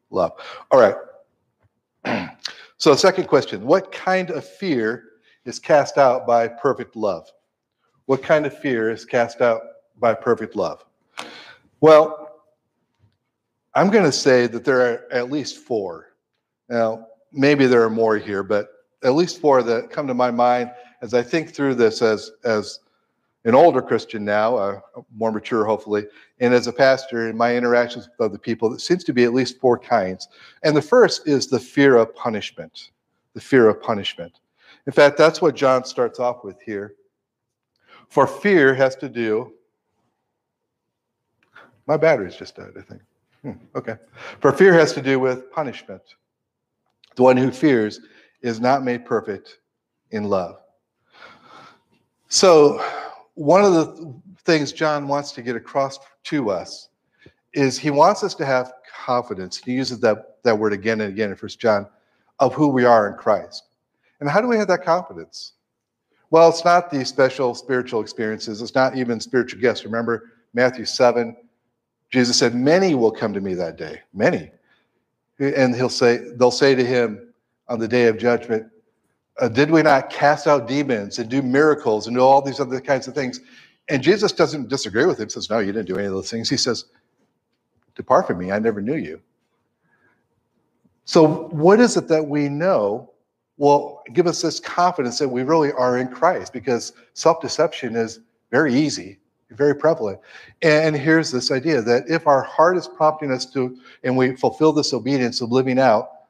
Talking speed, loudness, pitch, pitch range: 170 wpm, -19 LUFS, 130 Hz, 120-150 Hz